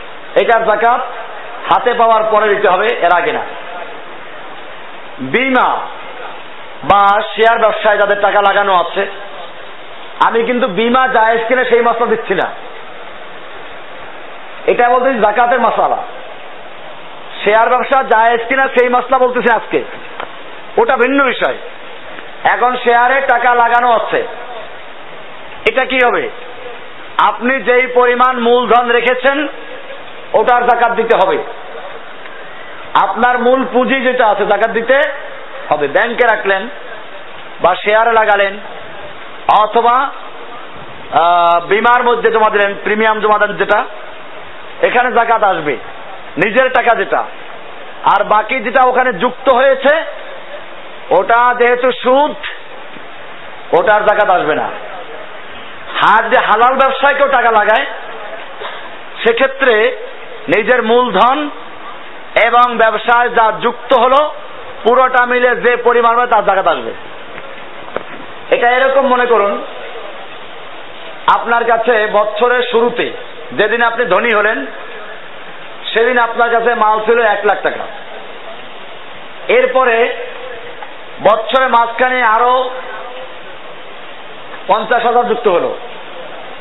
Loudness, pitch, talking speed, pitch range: -12 LUFS, 240 Hz, 105 wpm, 220-255 Hz